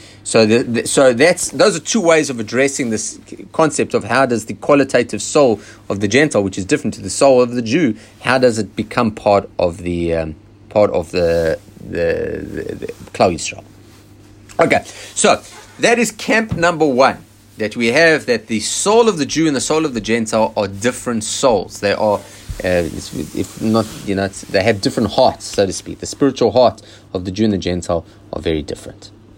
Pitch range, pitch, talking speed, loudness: 100-140 Hz, 110 Hz, 200 wpm, -16 LUFS